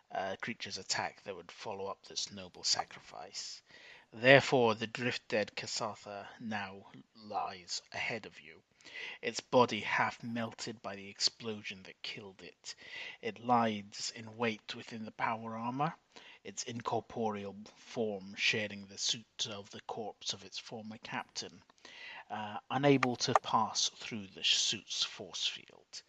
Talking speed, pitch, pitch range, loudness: 140 wpm, 115 Hz, 105-130 Hz, -35 LUFS